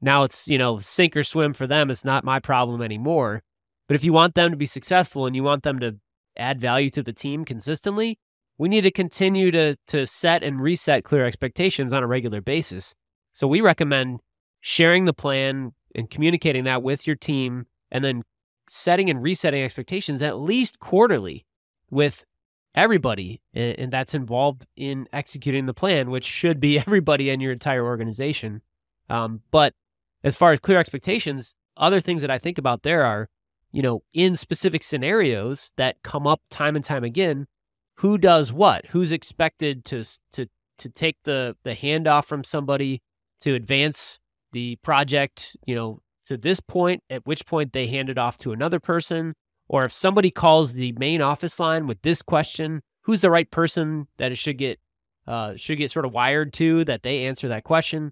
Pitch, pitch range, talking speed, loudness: 140 Hz, 125-160 Hz, 185 wpm, -22 LUFS